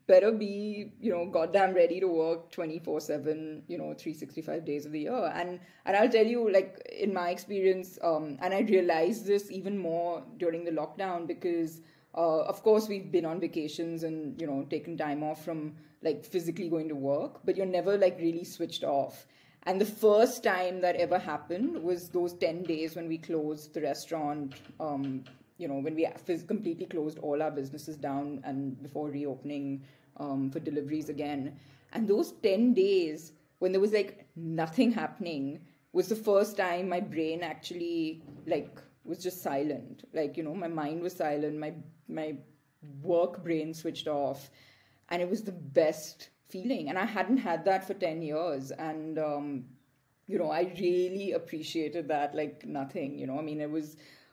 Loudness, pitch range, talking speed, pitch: -32 LUFS, 150-185 Hz, 180 wpm, 165 Hz